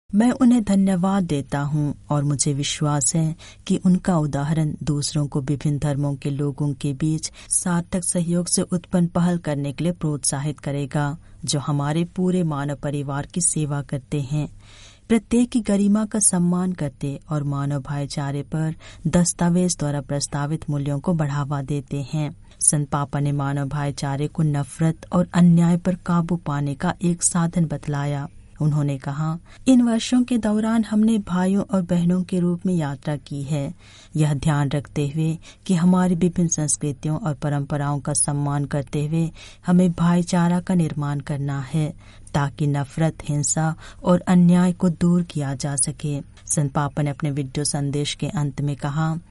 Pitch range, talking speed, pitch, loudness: 145-175 Hz, 155 wpm, 150 Hz, -22 LUFS